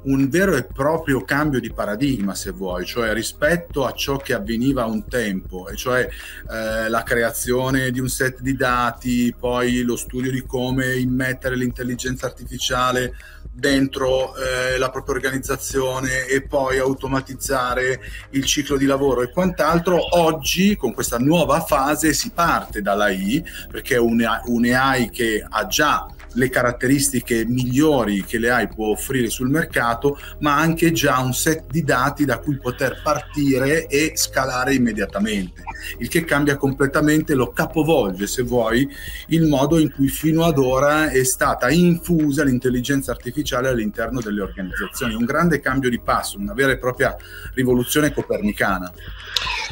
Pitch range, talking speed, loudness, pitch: 120-145 Hz, 150 wpm, -20 LUFS, 130 Hz